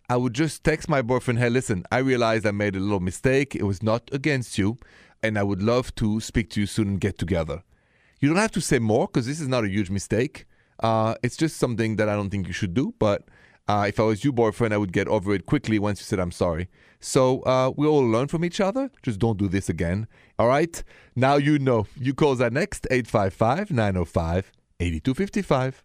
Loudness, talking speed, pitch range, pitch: -24 LUFS, 230 wpm, 105-135 Hz, 115 Hz